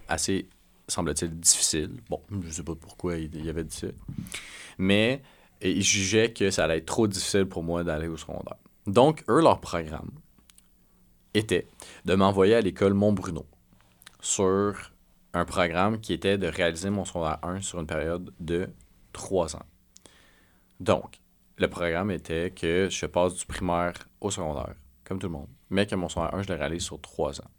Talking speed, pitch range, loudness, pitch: 175 wpm, 80-95 Hz, -27 LUFS, 90 Hz